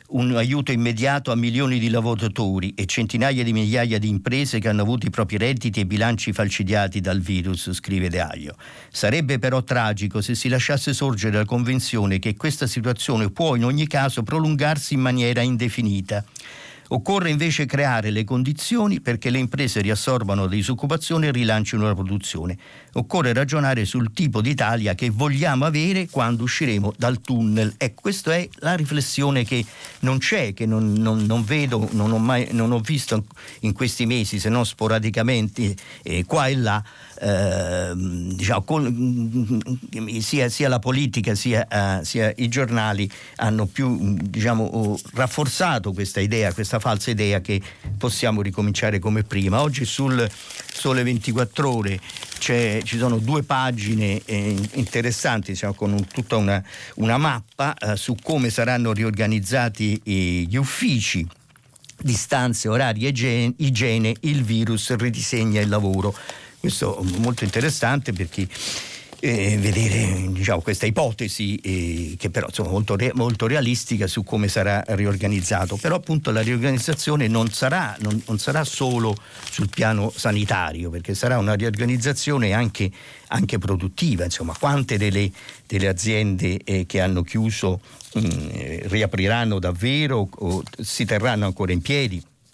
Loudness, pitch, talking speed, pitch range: -22 LUFS, 115 Hz, 145 wpm, 105-130 Hz